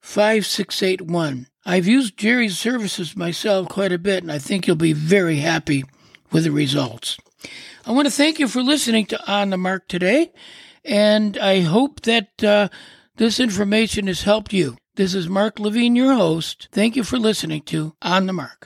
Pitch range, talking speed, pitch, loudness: 175-220 Hz, 175 wpm, 200 Hz, -19 LUFS